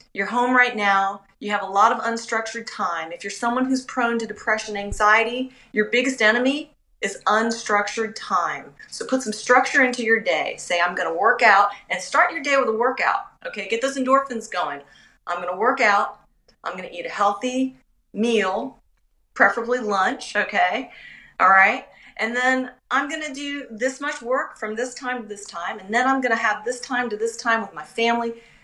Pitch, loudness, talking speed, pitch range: 230 Hz, -21 LUFS, 200 wpm, 210-255 Hz